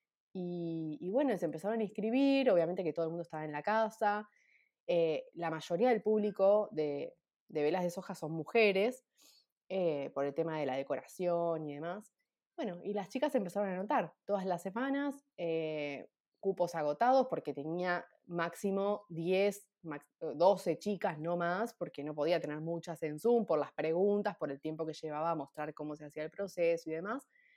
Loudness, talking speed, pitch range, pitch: -35 LUFS, 180 wpm, 160-210 Hz, 175 Hz